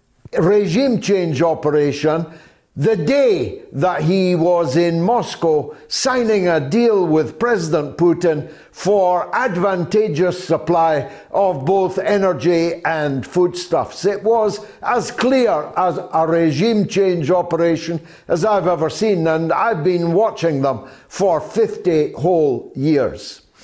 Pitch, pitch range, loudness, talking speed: 175 Hz, 160-200 Hz, -17 LUFS, 115 wpm